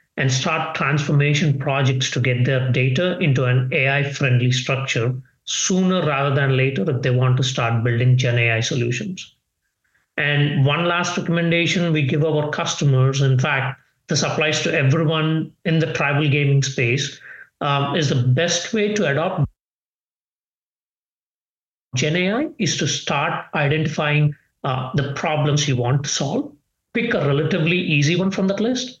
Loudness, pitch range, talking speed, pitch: -19 LUFS, 135-165 Hz, 150 wpm, 145 Hz